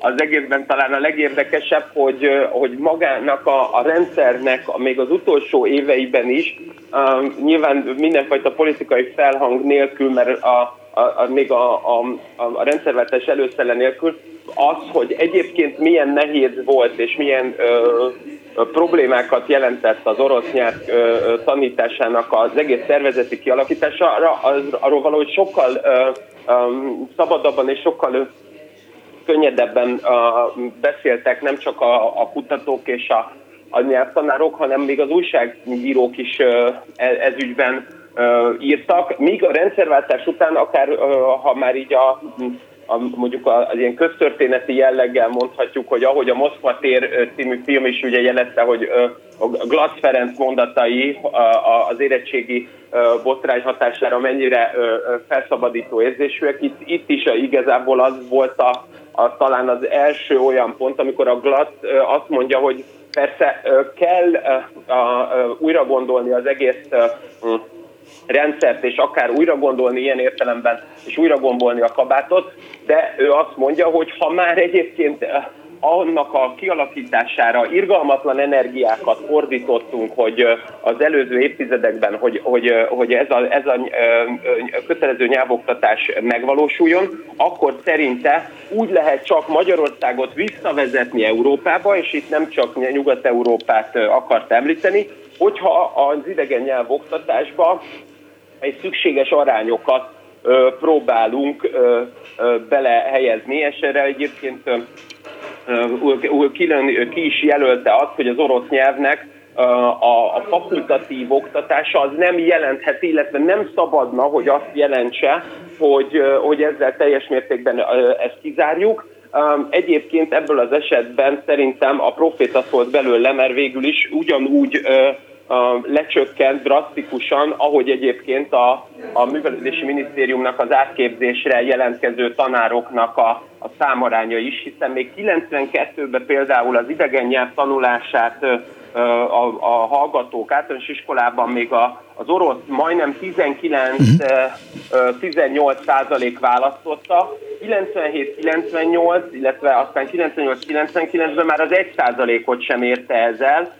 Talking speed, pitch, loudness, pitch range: 120 wpm, 140 Hz, -17 LUFS, 125-165 Hz